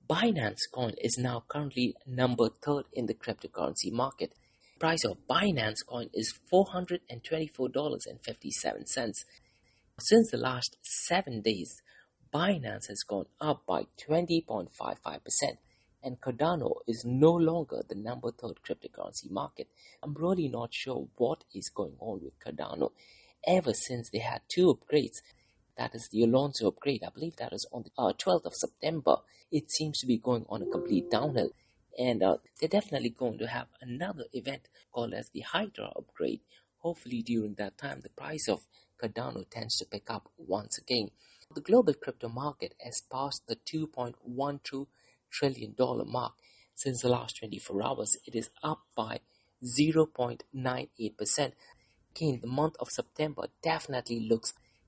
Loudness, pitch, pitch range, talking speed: -32 LUFS, 130 Hz, 120-155 Hz, 155 wpm